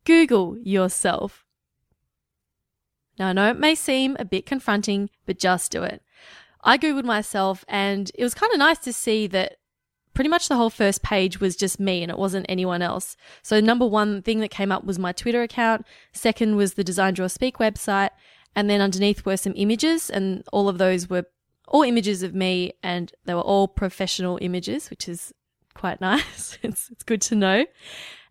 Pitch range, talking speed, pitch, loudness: 190-230 Hz, 185 wpm, 200 Hz, -22 LUFS